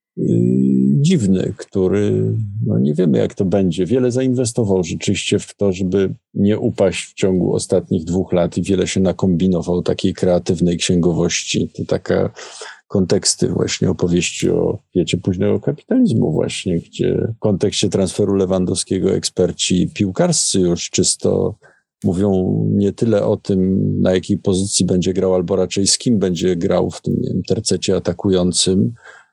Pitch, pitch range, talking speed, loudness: 95 Hz, 90-100 Hz, 140 wpm, -17 LUFS